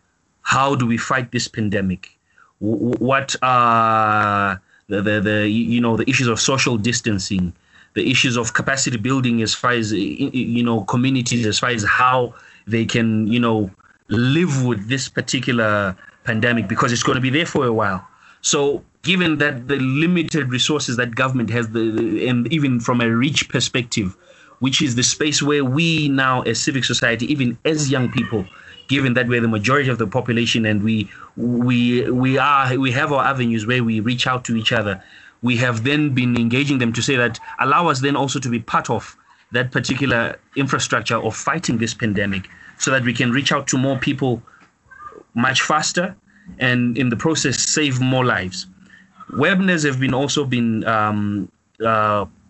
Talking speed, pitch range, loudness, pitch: 175 wpm, 115-135 Hz, -18 LUFS, 125 Hz